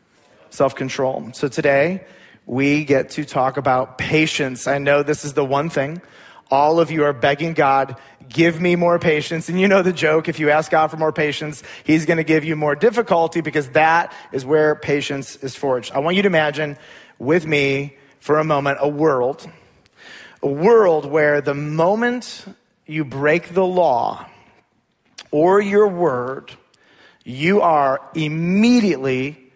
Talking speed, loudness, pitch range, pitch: 160 wpm, -18 LUFS, 140-170 Hz, 150 Hz